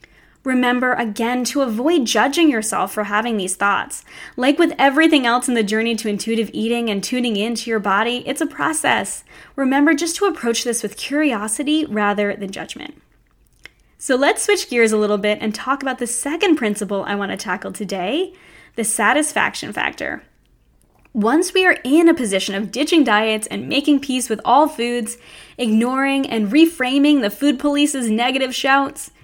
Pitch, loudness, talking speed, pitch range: 245 Hz, -18 LUFS, 170 wpm, 215-290 Hz